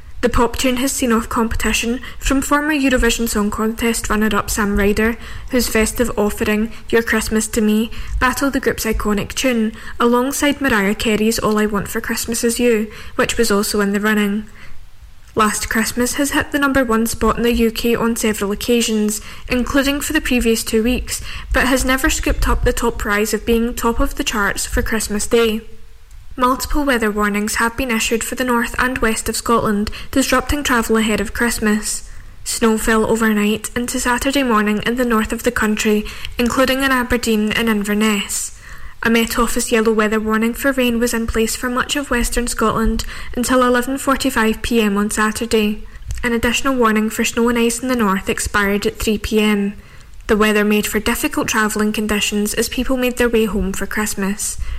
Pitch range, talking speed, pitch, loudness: 215-245 Hz, 180 wpm, 230 Hz, -17 LUFS